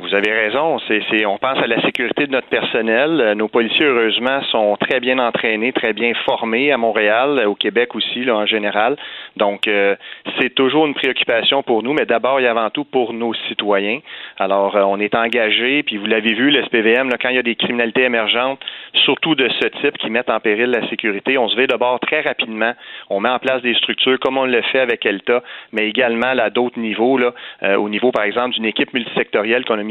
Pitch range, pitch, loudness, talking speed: 110-125 Hz, 115 Hz, -16 LUFS, 215 wpm